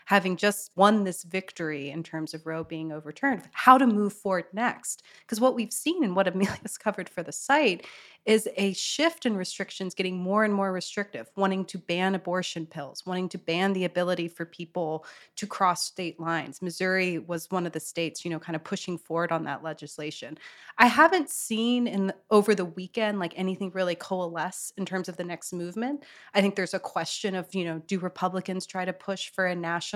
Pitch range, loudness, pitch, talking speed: 170-200 Hz, -28 LUFS, 185 Hz, 205 wpm